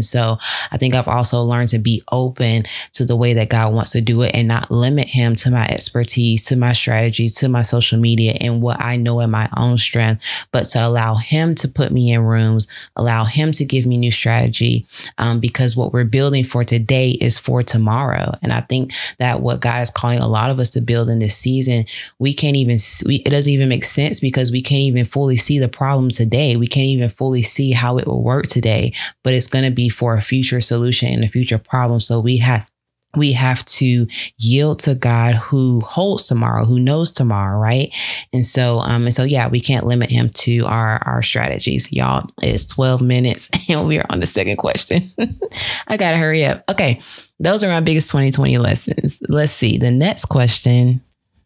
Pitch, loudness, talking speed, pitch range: 120 Hz, -16 LUFS, 210 wpm, 115-130 Hz